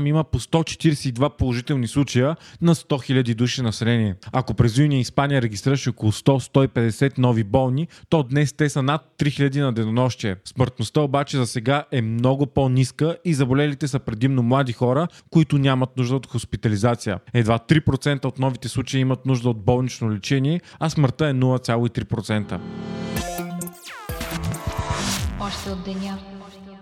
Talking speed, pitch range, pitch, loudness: 135 wpm, 120-150 Hz, 135 Hz, -22 LUFS